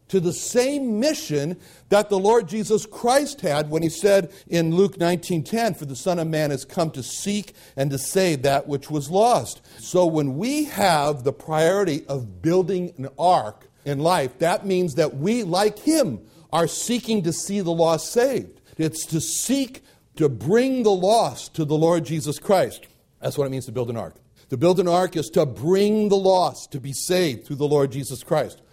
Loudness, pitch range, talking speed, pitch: -22 LUFS, 145-195 Hz, 195 wpm, 170 Hz